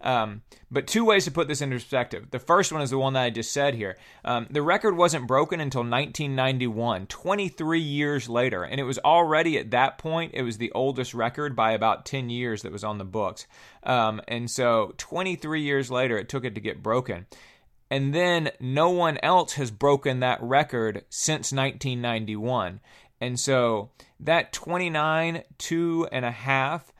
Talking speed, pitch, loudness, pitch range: 180 wpm, 135 Hz, -25 LUFS, 120-160 Hz